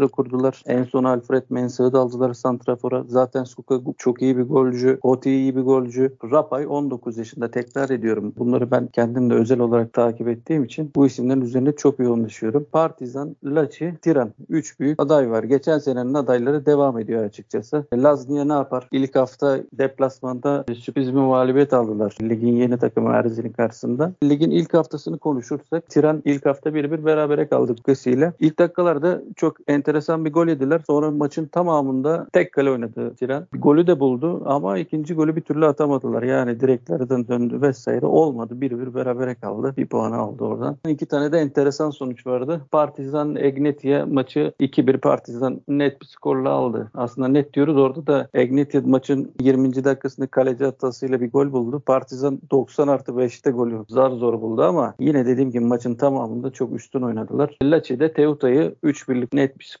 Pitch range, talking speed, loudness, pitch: 125-145 Hz, 170 wpm, -20 LUFS, 135 Hz